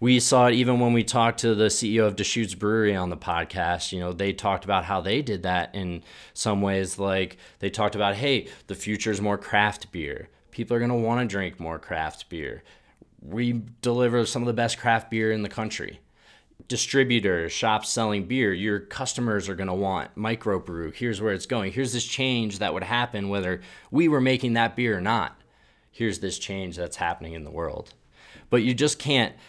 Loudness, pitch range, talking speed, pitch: -25 LUFS, 95-120 Hz, 200 wpm, 110 Hz